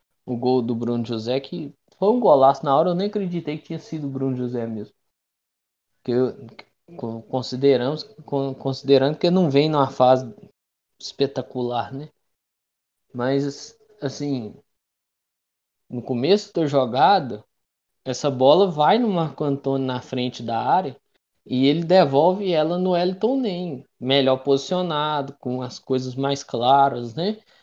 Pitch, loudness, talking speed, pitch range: 135 Hz, -21 LUFS, 140 wpm, 125-155 Hz